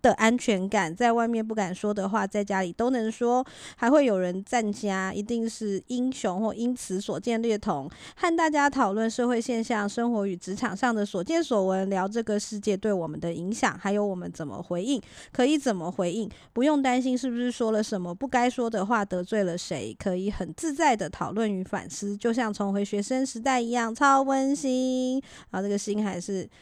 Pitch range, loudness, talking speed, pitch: 195-245 Hz, -27 LUFS, 300 characters per minute, 220 Hz